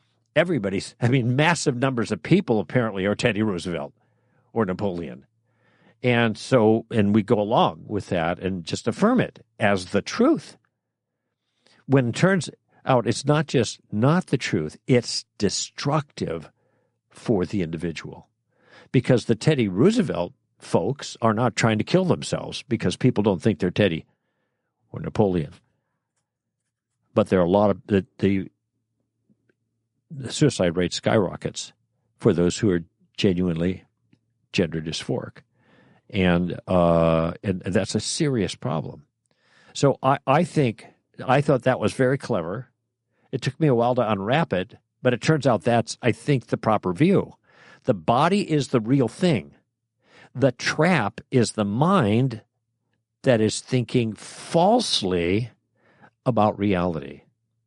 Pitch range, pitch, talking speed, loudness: 100-130 Hz, 115 Hz, 140 wpm, -23 LUFS